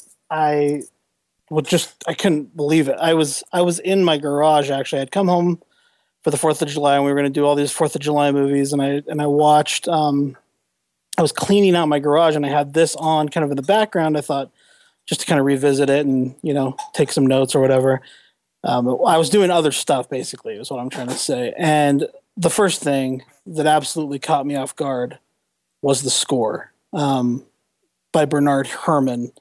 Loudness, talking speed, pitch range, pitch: -18 LUFS, 210 wpm, 140-160 Hz, 145 Hz